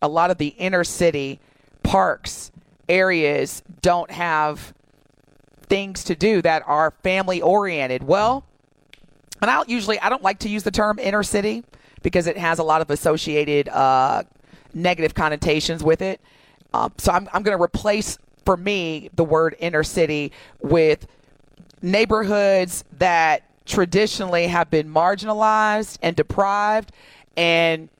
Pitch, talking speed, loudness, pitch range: 170 Hz, 140 wpm, -20 LUFS, 150-195 Hz